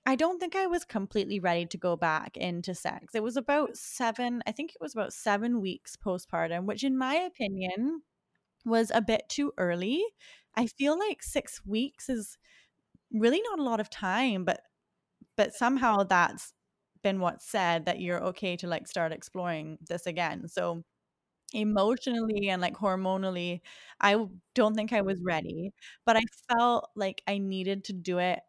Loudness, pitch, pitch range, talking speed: -30 LUFS, 210 Hz, 180-240 Hz, 170 wpm